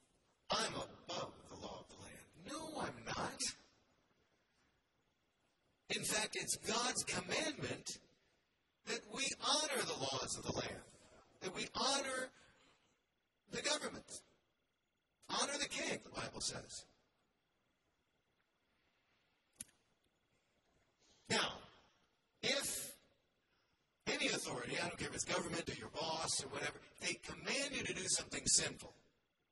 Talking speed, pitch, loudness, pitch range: 115 wpm, 230 Hz, -40 LUFS, 185-260 Hz